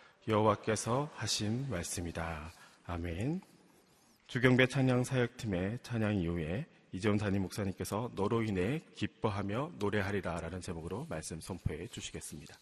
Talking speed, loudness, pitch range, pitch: 320 characters per minute, -35 LUFS, 90-120 Hz, 105 Hz